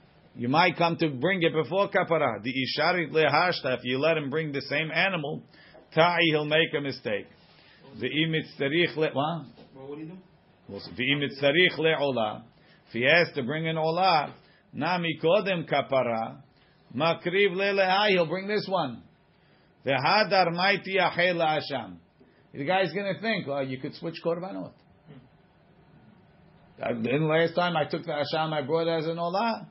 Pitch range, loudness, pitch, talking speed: 145-180 Hz, -26 LUFS, 160 Hz, 150 wpm